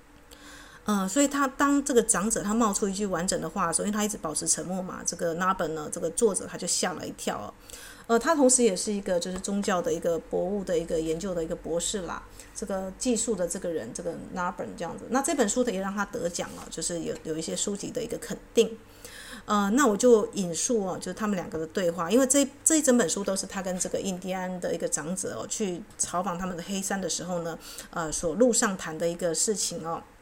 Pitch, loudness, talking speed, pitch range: 195 Hz, -27 LUFS, 355 characters per minute, 175-230 Hz